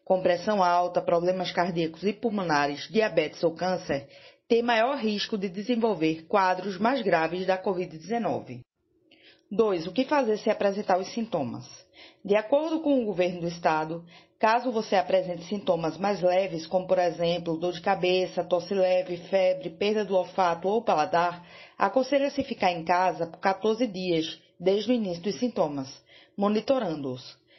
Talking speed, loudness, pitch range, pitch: 145 wpm, -27 LUFS, 175-215 Hz, 185 Hz